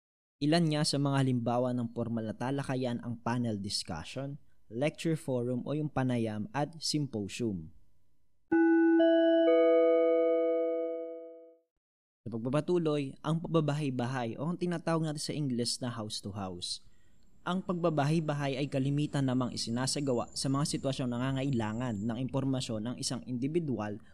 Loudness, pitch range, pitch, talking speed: -31 LUFS, 120-160 Hz, 135 Hz, 115 wpm